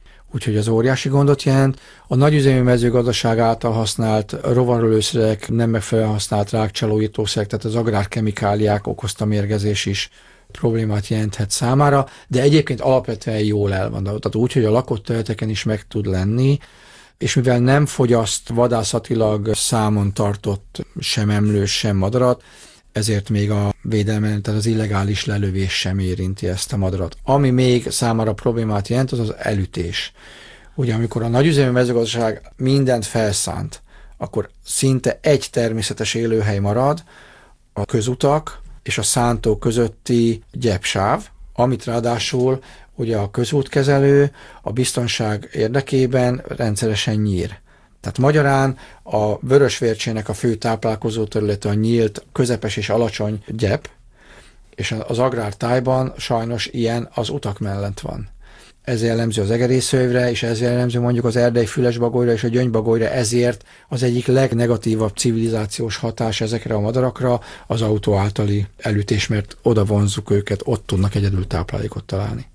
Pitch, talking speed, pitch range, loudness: 115 Hz, 130 wpm, 105-125 Hz, -19 LUFS